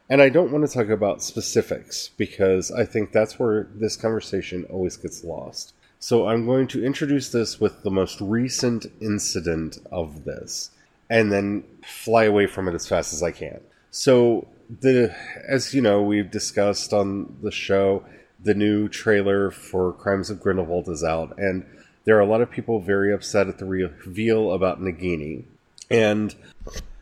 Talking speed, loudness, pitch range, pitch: 170 wpm, -22 LUFS, 95-115 Hz, 100 Hz